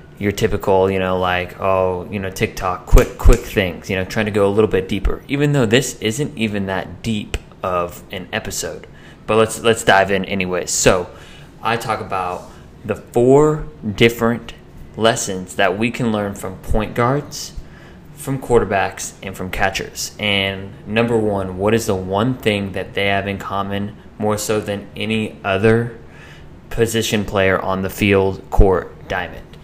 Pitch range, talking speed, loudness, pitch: 95-115 Hz, 165 wpm, -18 LUFS, 100 Hz